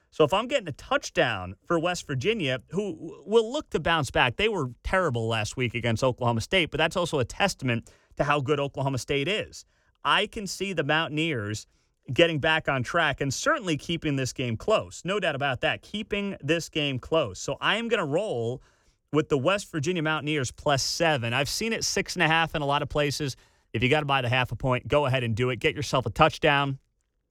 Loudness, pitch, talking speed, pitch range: -26 LUFS, 145 Hz, 220 wpm, 125-165 Hz